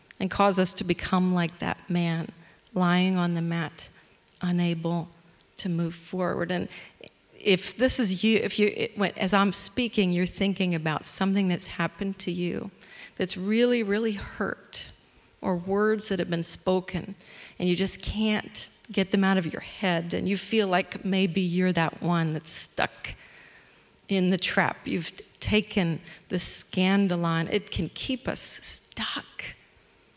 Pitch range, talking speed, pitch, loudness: 170-200 Hz, 155 wpm, 185 Hz, -27 LUFS